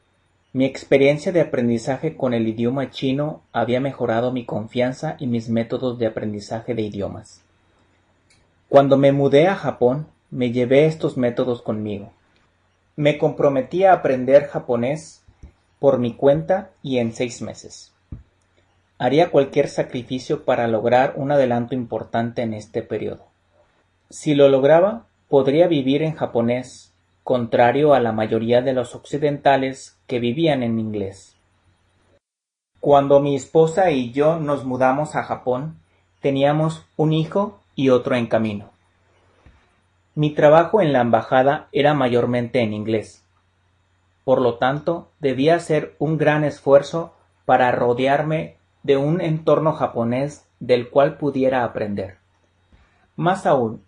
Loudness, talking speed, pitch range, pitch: -19 LUFS, 130 wpm, 110-145 Hz, 125 Hz